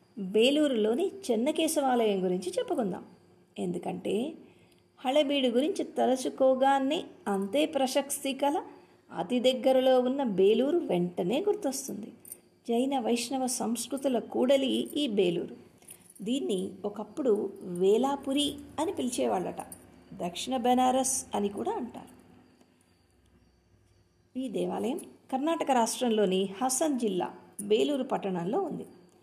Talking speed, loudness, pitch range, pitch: 85 wpm, -29 LUFS, 200-275 Hz, 255 Hz